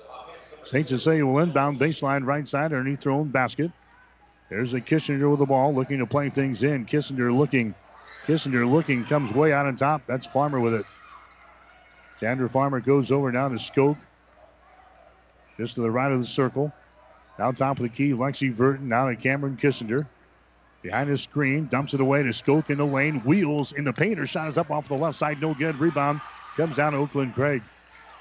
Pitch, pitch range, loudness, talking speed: 140 Hz, 130-145 Hz, -24 LUFS, 190 wpm